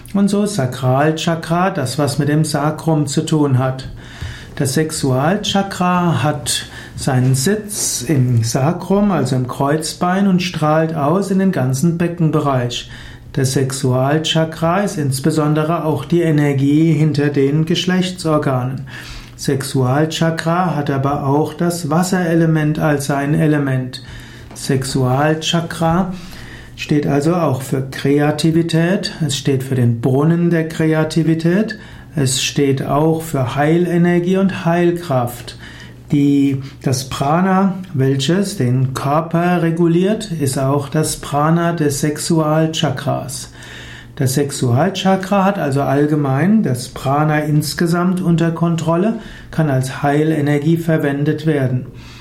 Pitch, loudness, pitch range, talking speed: 150 Hz, -16 LUFS, 135-170 Hz, 110 wpm